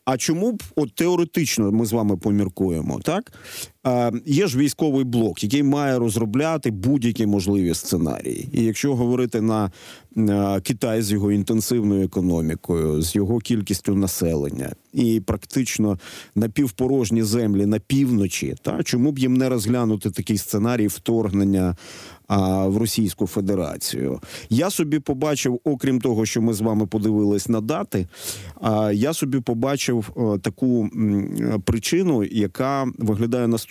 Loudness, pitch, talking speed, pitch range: -22 LUFS, 110 Hz, 130 wpm, 100-130 Hz